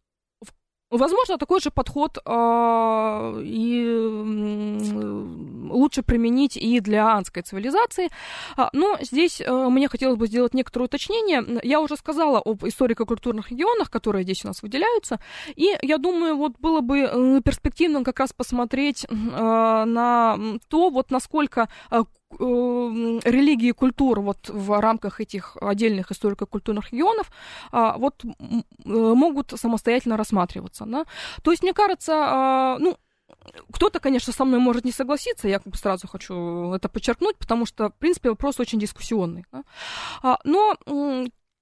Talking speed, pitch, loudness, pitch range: 130 wpm, 245 Hz, -22 LUFS, 220-295 Hz